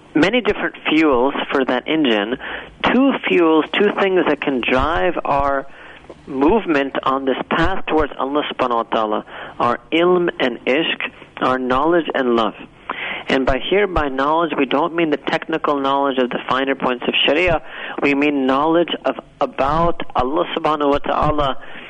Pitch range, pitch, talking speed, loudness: 135-170 Hz, 145 Hz, 155 wpm, -18 LUFS